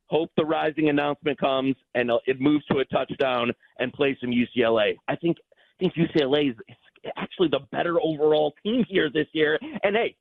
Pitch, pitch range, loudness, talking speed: 150 Hz, 135-160 Hz, -24 LUFS, 180 wpm